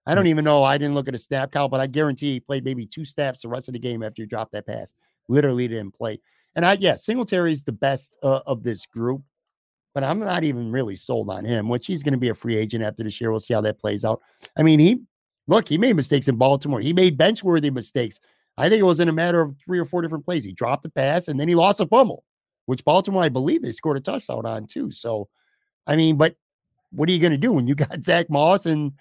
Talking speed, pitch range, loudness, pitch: 265 wpm, 125-170 Hz, -21 LUFS, 140 Hz